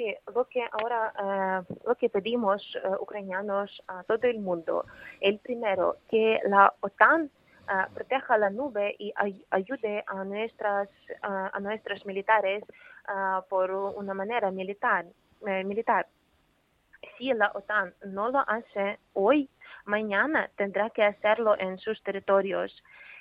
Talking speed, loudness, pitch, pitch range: 135 wpm, -28 LUFS, 205 Hz, 195-230 Hz